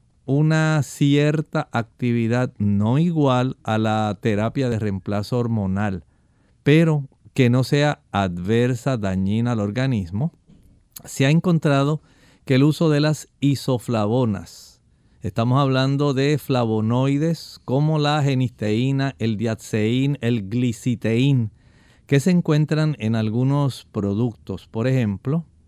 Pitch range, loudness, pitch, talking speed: 110-145 Hz, -21 LUFS, 125 Hz, 110 wpm